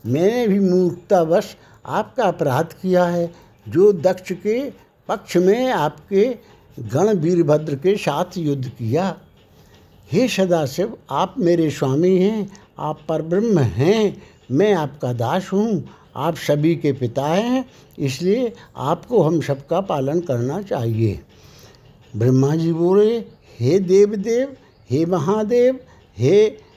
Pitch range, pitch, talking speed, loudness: 140-200 Hz, 175 Hz, 120 wpm, -19 LUFS